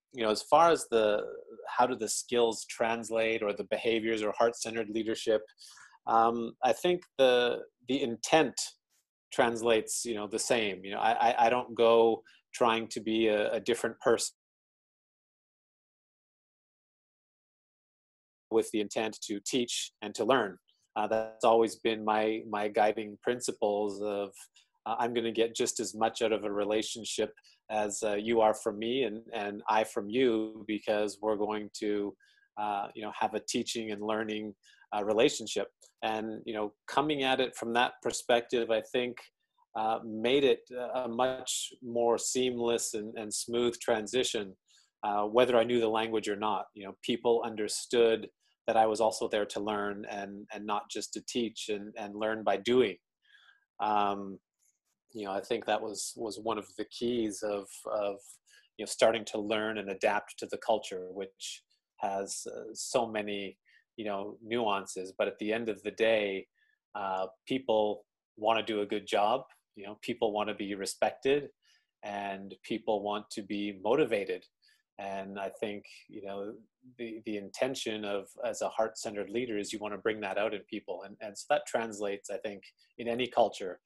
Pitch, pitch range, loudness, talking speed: 110 Hz, 105-120 Hz, -32 LUFS, 170 wpm